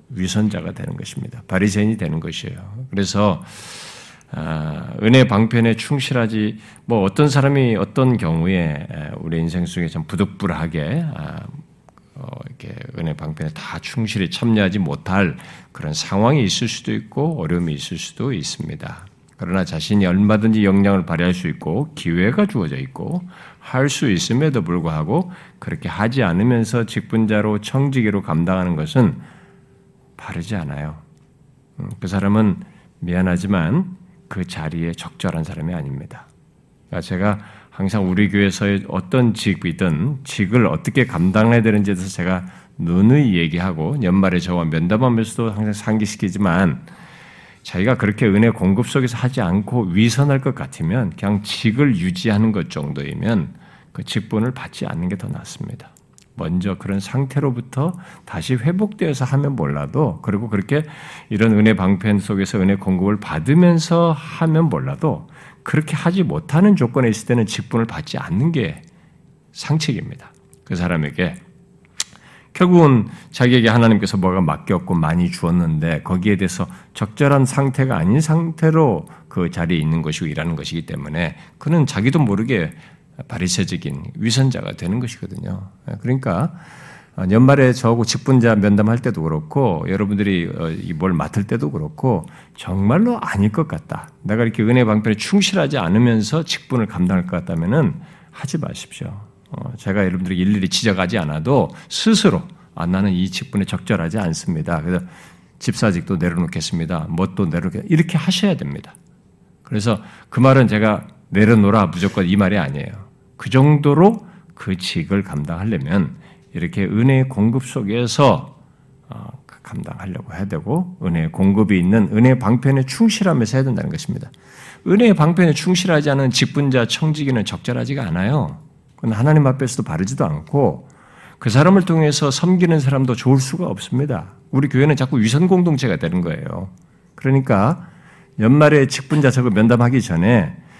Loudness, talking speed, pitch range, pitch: -18 LUFS, 330 characters per minute, 100-145 Hz, 120 Hz